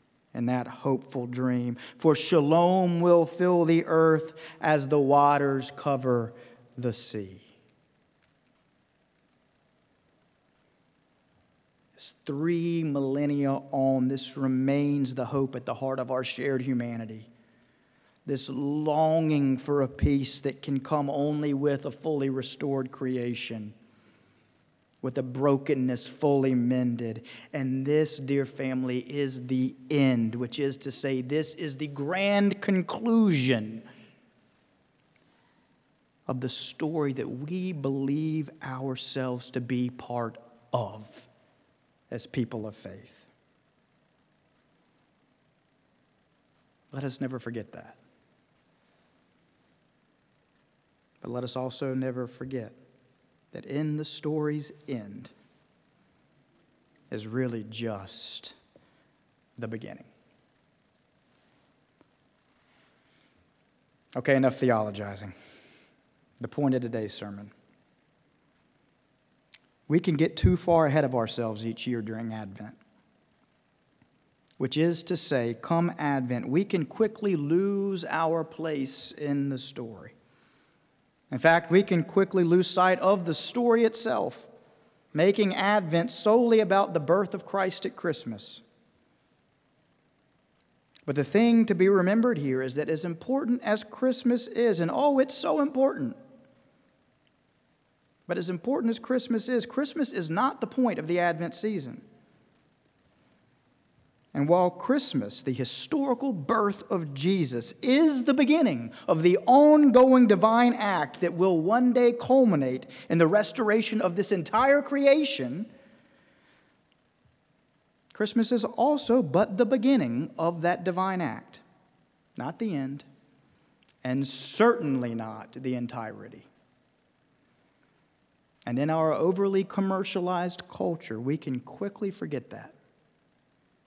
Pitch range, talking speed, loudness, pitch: 130-195 Hz, 110 wpm, -27 LUFS, 150 Hz